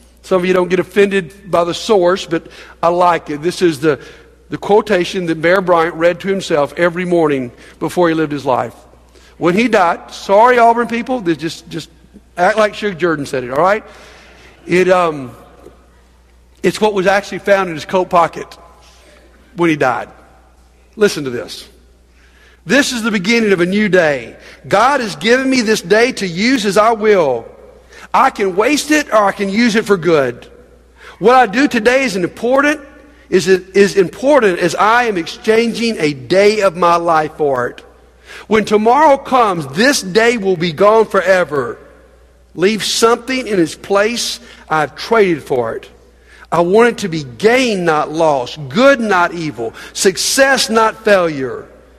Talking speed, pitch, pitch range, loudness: 170 wpm, 190 Hz, 165-230 Hz, -13 LUFS